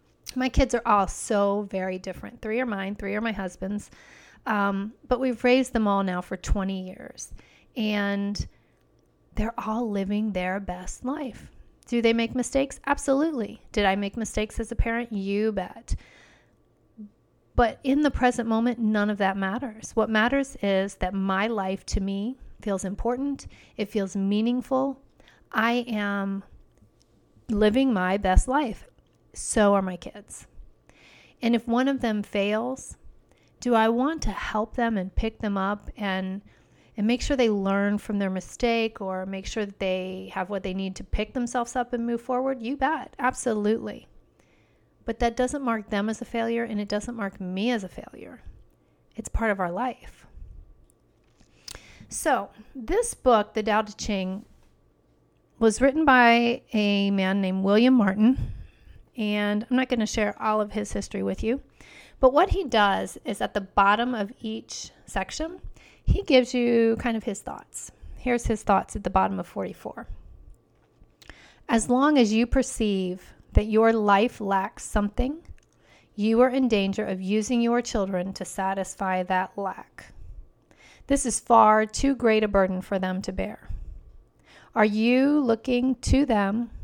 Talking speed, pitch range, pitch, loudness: 160 wpm, 200-245 Hz, 215 Hz, -25 LUFS